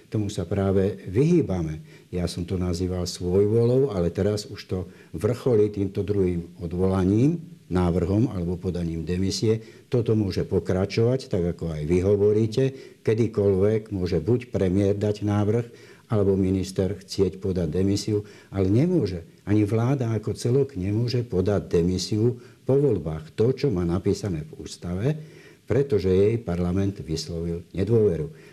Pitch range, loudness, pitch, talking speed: 90-110 Hz, -24 LUFS, 100 Hz, 130 wpm